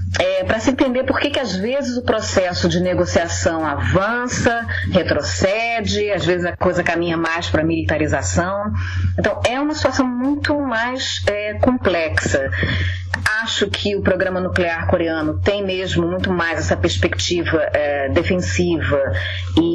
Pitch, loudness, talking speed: 175 Hz, -19 LUFS, 140 wpm